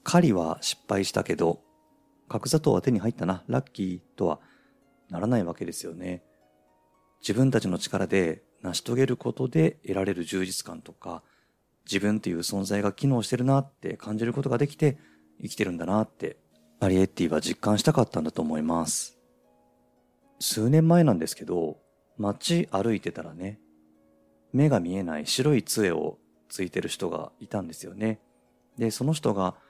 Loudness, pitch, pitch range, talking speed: -27 LUFS, 95 Hz, 80-120 Hz, 320 characters per minute